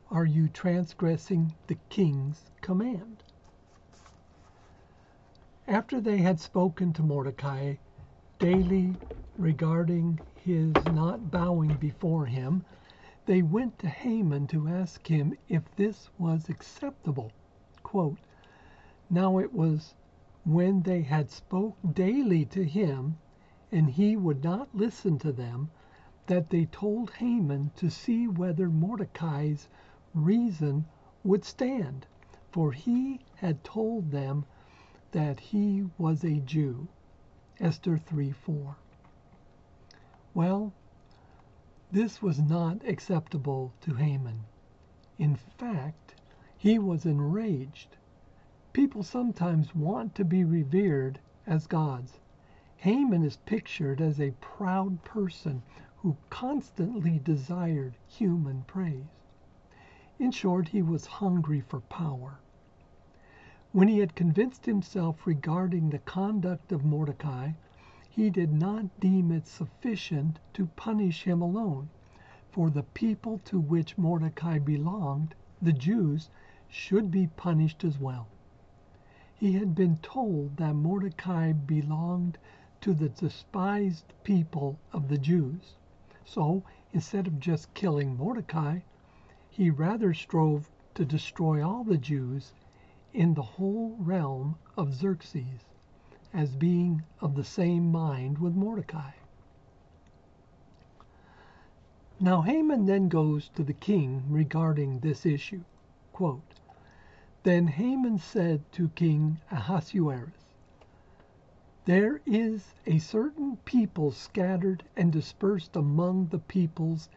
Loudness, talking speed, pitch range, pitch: -29 LUFS, 110 wpm, 145-190 Hz, 165 Hz